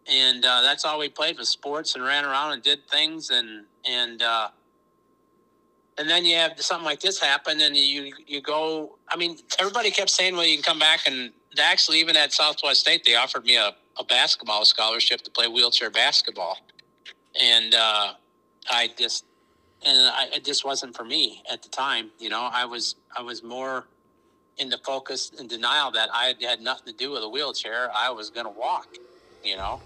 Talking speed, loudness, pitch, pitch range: 195 wpm, -21 LUFS, 140 Hz, 120-155 Hz